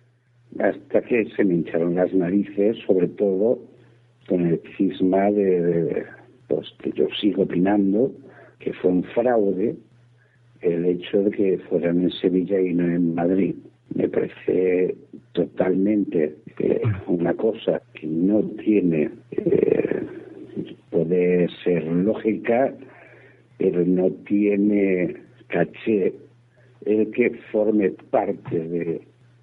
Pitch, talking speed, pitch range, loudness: 95 Hz, 115 wpm, 90-115 Hz, -22 LUFS